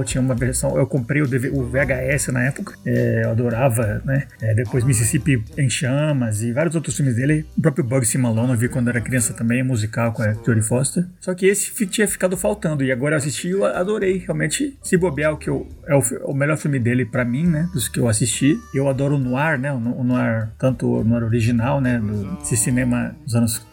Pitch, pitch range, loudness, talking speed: 130 Hz, 120-150 Hz, -20 LUFS, 225 wpm